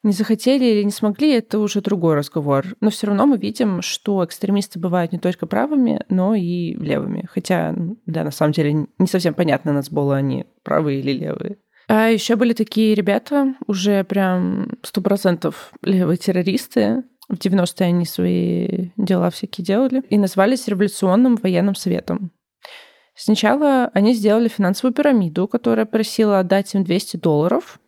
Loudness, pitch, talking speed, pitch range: -19 LUFS, 200 Hz, 155 wpm, 180-225 Hz